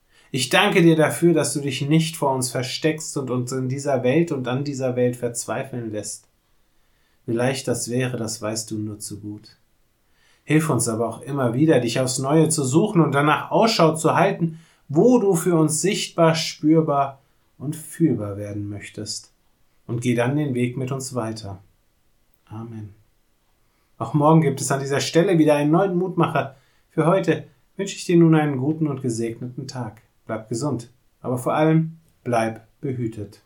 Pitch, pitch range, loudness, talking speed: 135 Hz, 115-155 Hz, -21 LUFS, 170 wpm